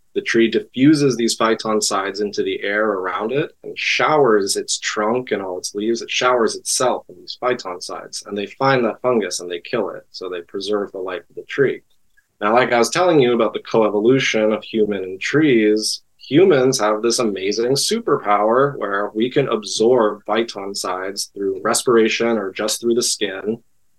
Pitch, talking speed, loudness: 115 Hz, 190 wpm, -18 LUFS